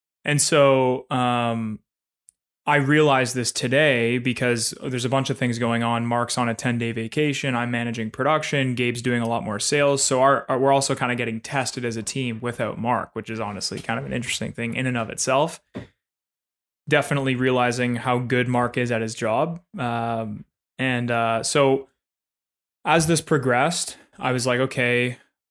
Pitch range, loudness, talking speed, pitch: 120-135 Hz, -22 LUFS, 180 wpm, 125 Hz